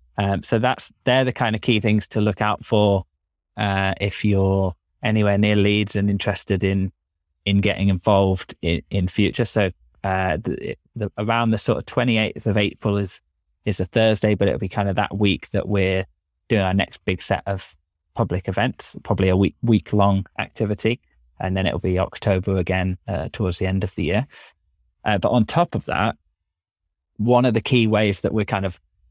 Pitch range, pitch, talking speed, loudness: 90-105 Hz, 100 Hz, 195 wpm, -21 LUFS